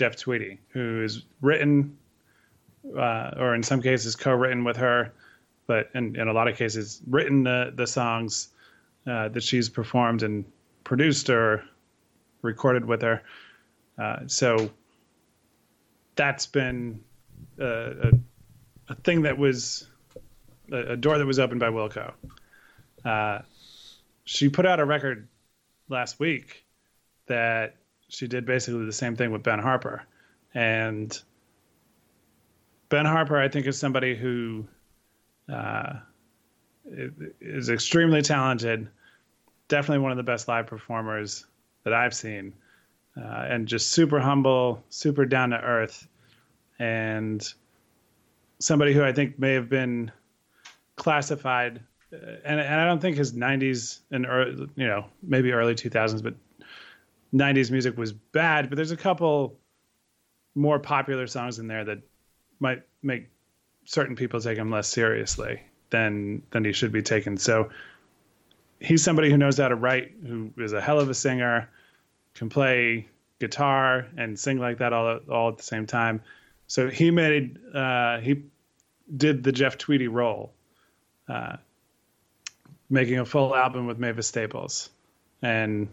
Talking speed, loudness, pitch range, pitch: 140 wpm, -25 LUFS, 115-135 Hz, 120 Hz